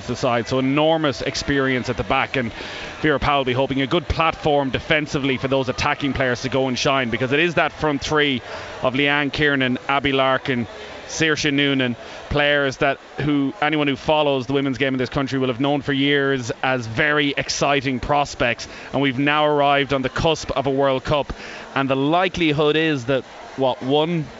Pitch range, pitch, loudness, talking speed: 130-150 Hz, 140 Hz, -20 LUFS, 190 wpm